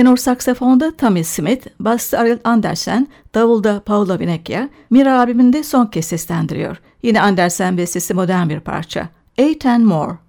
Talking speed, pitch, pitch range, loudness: 140 wpm, 225 Hz, 180-250 Hz, -15 LUFS